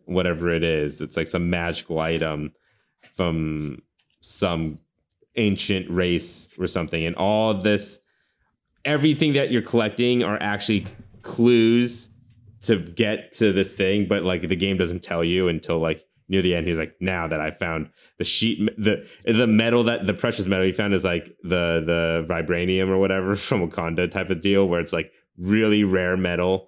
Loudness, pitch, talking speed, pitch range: -22 LUFS, 95 Hz, 170 wpm, 85-105 Hz